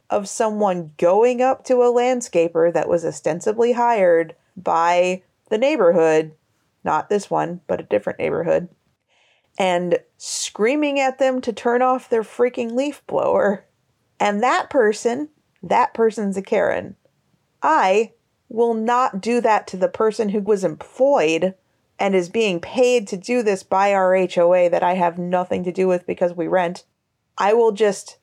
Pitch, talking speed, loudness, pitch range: 210 Hz, 155 wpm, -19 LUFS, 180-245 Hz